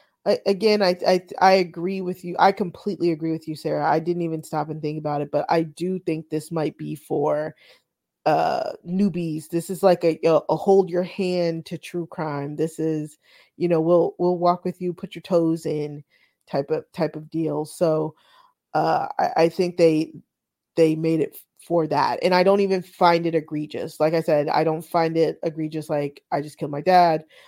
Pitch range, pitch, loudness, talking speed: 155-180 Hz, 165 Hz, -23 LUFS, 205 wpm